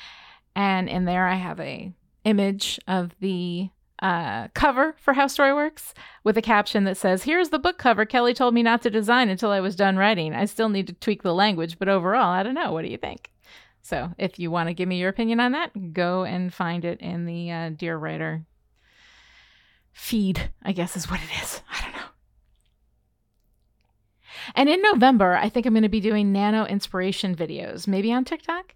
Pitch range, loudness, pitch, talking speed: 175-230 Hz, -23 LUFS, 195 Hz, 200 wpm